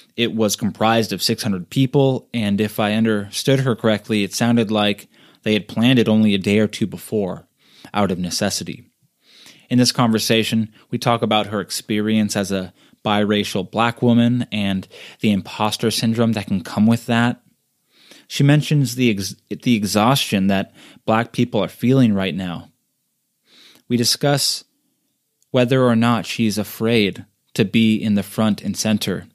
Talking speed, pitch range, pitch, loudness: 155 wpm, 105-120 Hz, 110 Hz, -19 LUFS